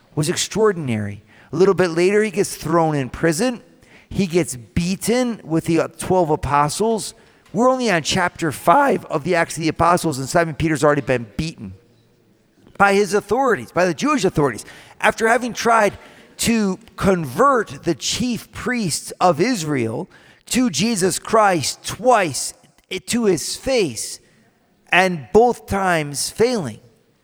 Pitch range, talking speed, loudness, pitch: 155-215 Hz, 140 wpm, -19 LUFS, 180 Hz